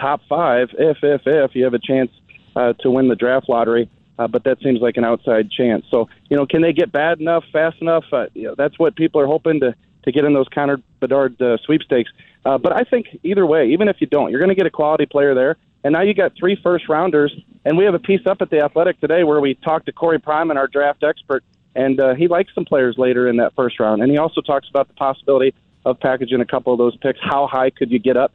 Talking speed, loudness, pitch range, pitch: 265 wpm, -17 LUFS, 130-160 Hz, 140 Hz